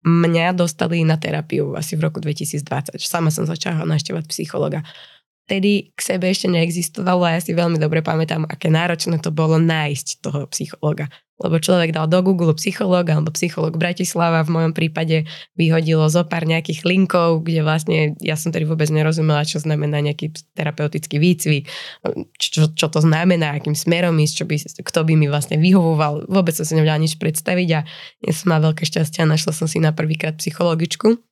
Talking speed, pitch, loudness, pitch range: 180 wpm, 160 Hz, -18 LUFS, 155-175 Hz